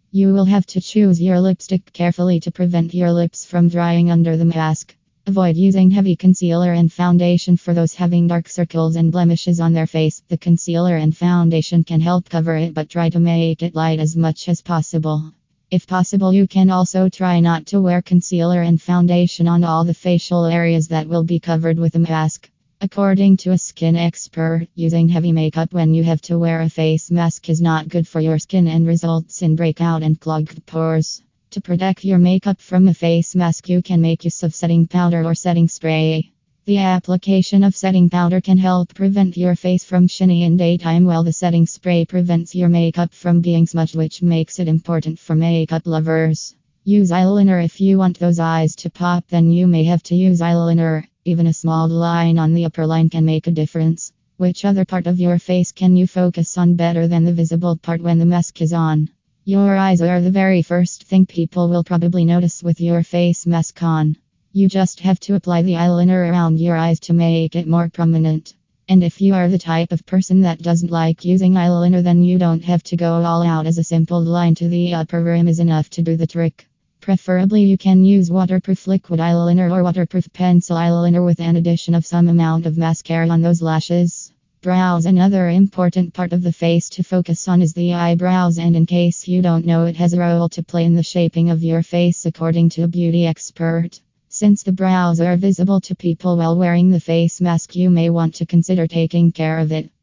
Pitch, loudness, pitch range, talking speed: 170 Hz, -16 LUFS, 165-180 Hz, 210 wpm